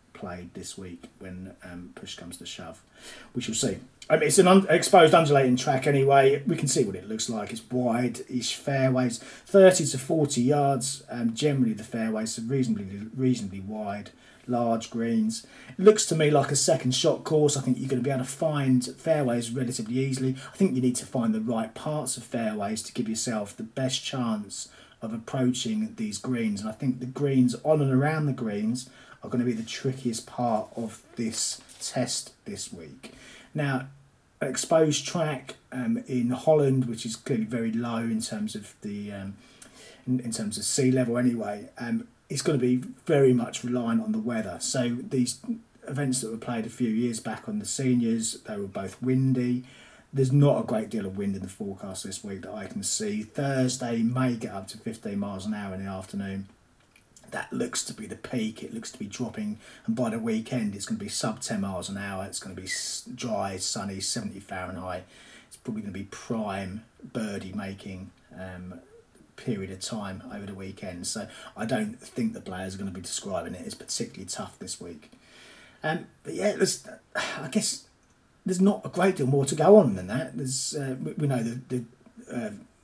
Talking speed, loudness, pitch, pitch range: 205 wpm, -27 LUFS, 125 Hz, 110-145 Hz